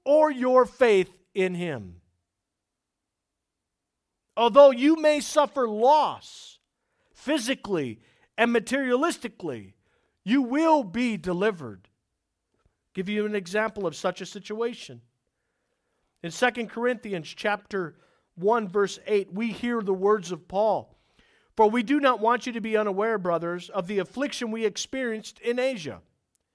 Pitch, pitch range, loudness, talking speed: 215 Hz, 185-250 Hz, -25 LUFS, 125 wpm